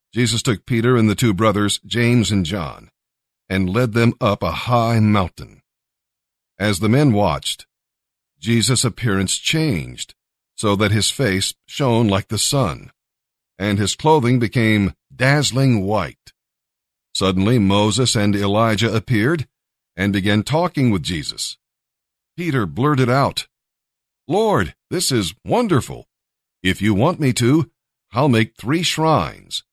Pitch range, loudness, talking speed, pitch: 100-125 Hz, -18 LUFS, 130 wpm, 115 Hz